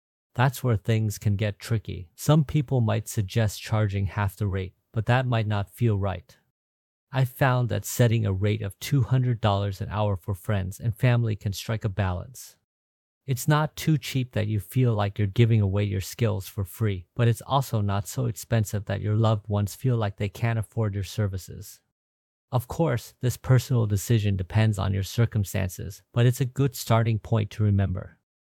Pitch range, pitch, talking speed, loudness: 100-120 Hz, 110 Hz, 185 wpm, -26 LUFS